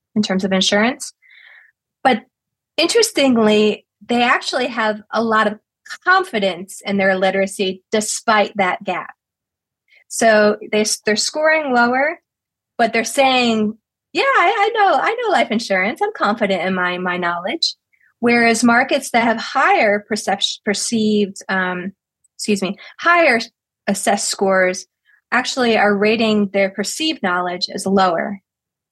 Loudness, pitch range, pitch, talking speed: -17 LUFS, 195-255 Hz, 215 Hz, 130 wpm